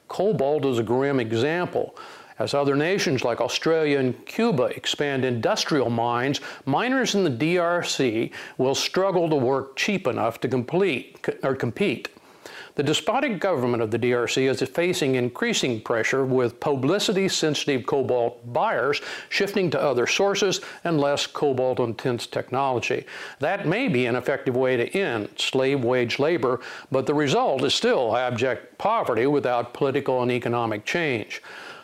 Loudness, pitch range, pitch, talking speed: -23 LUFS, 125-160 Hz, 135 Hz, 145 wpm